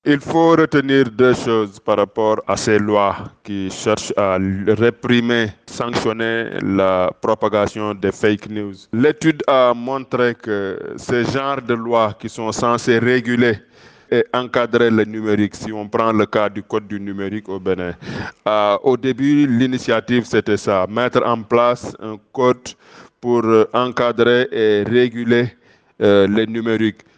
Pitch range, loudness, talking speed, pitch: 105-125 Hz, -17 LUFS, 145 wpm, 115 Hz